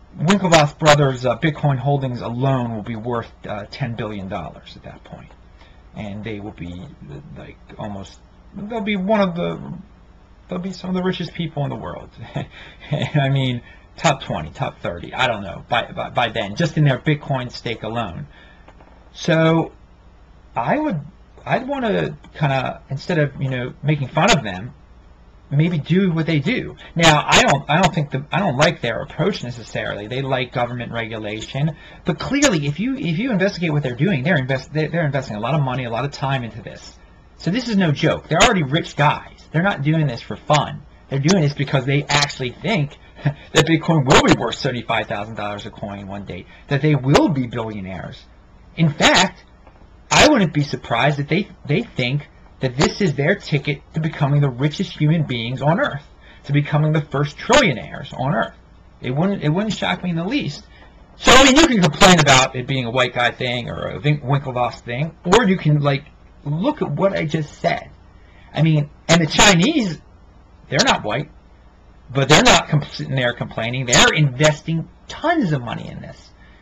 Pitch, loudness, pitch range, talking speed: 145 Hz, -18 LUFS, 120-165 Hz, 190 wpm